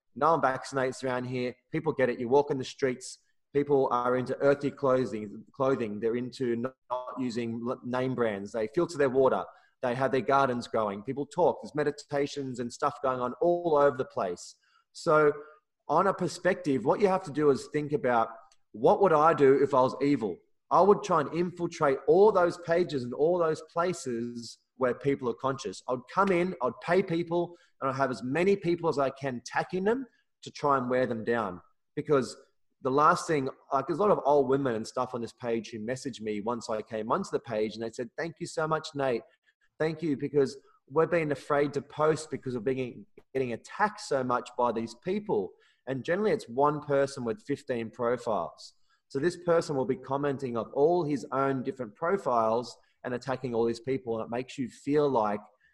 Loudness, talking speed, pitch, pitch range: -29 LUFS, 200 wpm, 135 Hz, 125-155 Hz